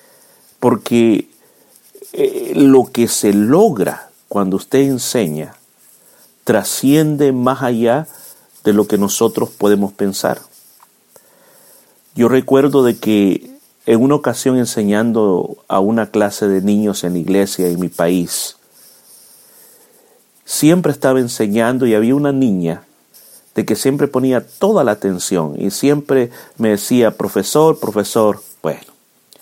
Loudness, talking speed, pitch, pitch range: -15 LUFS, 115 wpm, 115 Hz, 105-135 Hz